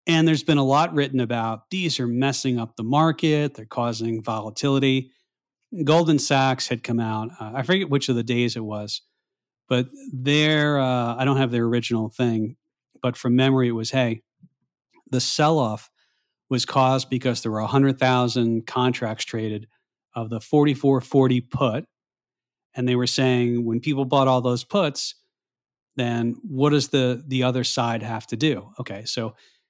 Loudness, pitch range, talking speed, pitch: -22 LUFS, 115-140 Hz, 165 wpm, 125 Hz